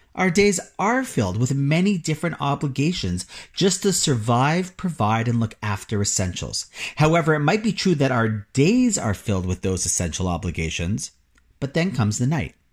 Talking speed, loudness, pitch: 165 wpm, -22 LUFS, 140 Hz